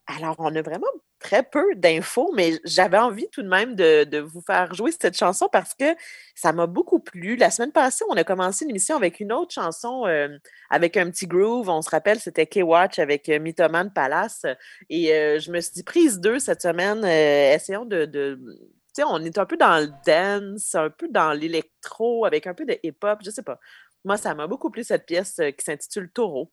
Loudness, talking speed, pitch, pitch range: -22 LUFS, 220 wpm, 185 Hz, 160-235 Hz